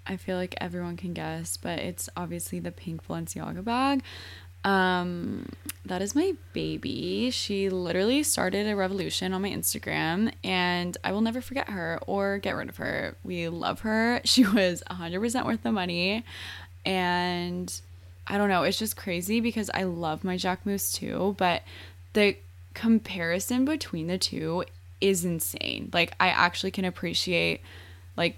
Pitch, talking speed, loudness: 180 Hz, 160 wpm, -28 LUFS